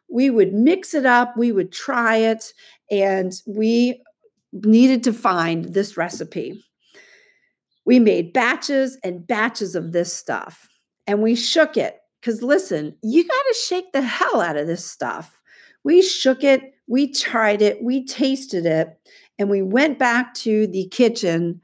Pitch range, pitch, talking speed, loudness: 200-270 Hz, 235 Hz, 155 wpm, -19 LUFS